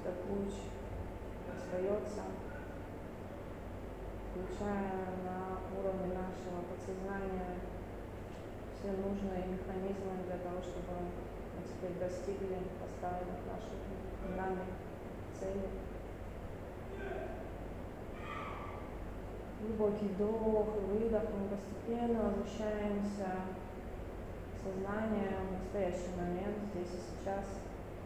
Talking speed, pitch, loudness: 75 wpm, 175 Hz, -41 LUFS